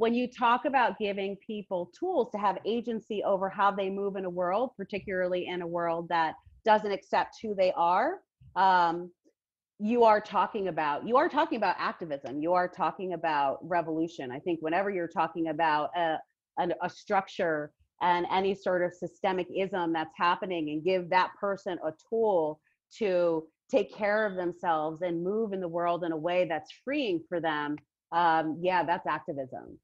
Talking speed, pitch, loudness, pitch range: 175 wpm, 180 Hz, -29 LUFS, 170-200 Hz